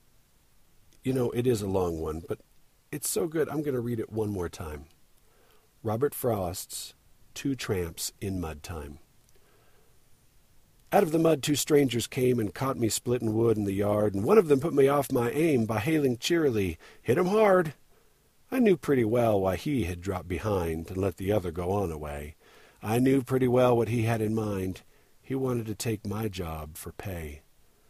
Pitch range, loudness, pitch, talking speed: 95-130 Hz, -28 LUFS, 110 Hz, 190 wpm